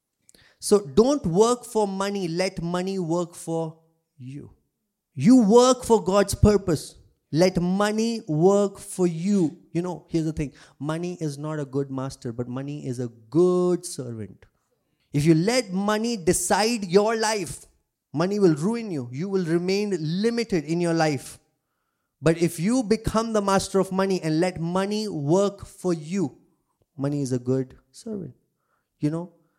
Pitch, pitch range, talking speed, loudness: 175 Hz, 155-200 Hz, 155 wpm, -24 LUFS